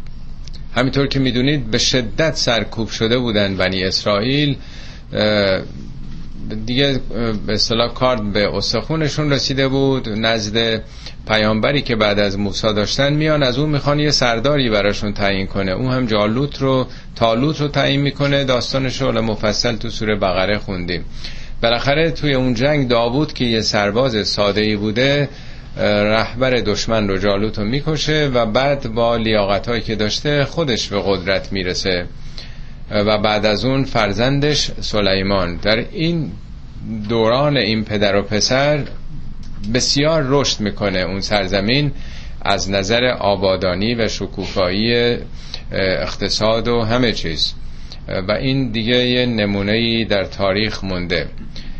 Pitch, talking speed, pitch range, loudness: 115 Hz, 125 wpm, 105-130 Hz, -17 LUFS